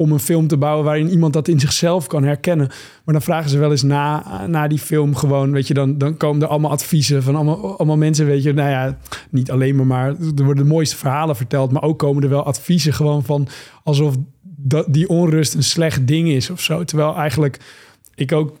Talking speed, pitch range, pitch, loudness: 230 wpm, 140-155 Hz, 150 Hz, -17 LUFS